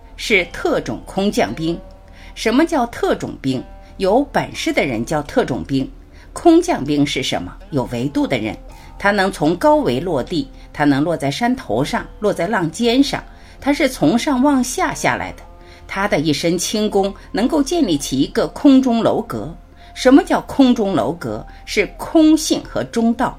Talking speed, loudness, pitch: 230 characters per minute, -17 LUFS, 220 Hz